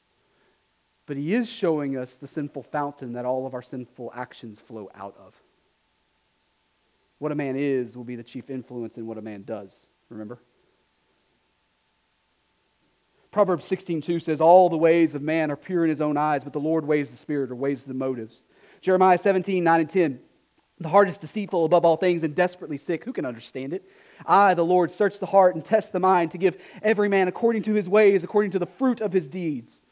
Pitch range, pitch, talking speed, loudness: 130-185 Hz, 160 Hz, 205 wpm, -23 LUFS